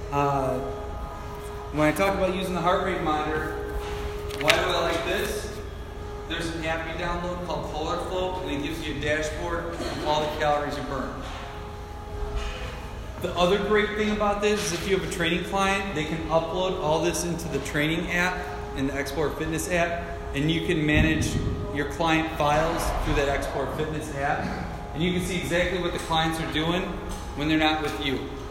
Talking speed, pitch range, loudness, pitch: 185 wpm, 135-175 Hz, -26 LUFS, 155 Hz